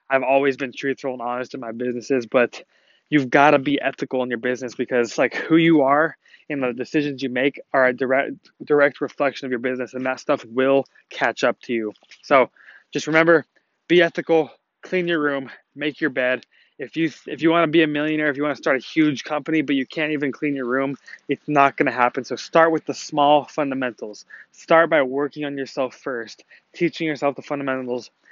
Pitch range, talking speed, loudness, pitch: 130-150 Hz, 210 wpm, -21 LUFS, 140 Hz